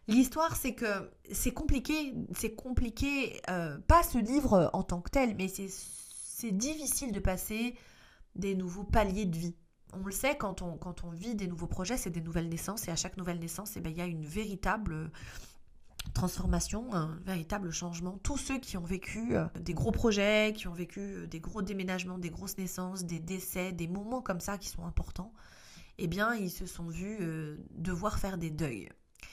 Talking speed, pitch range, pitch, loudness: 190 wpm, 175-215 Hz, 190 Hz, -34 LUFS